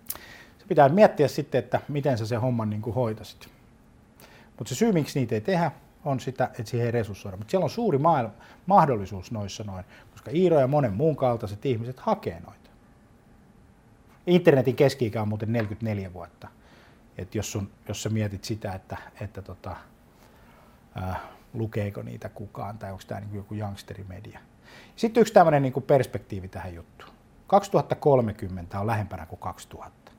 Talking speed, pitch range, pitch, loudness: 155 wpm, 105-140 Hz, 115 Hz, -25 LUFS